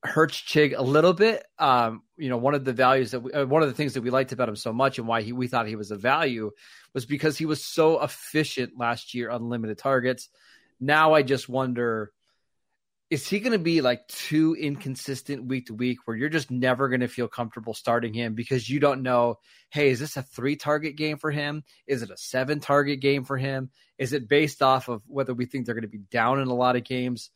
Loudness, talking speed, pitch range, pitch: -25 LUFS, 240 wpm, 120-145 Hz, 130 Hz